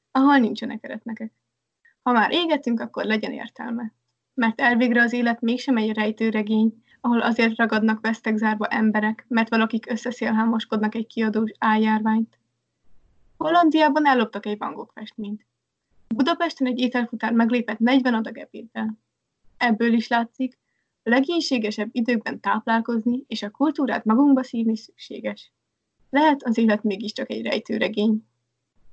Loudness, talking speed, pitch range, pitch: -22 LUFS, 120 wpm, 220-250 Hz, 230 Hz